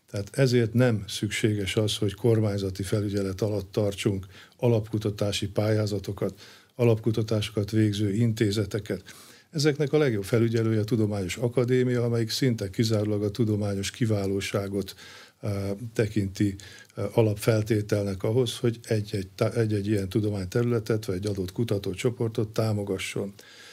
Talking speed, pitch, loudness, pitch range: 110 wpm, 110 Hz, -27 LUFS, 100-115 Hz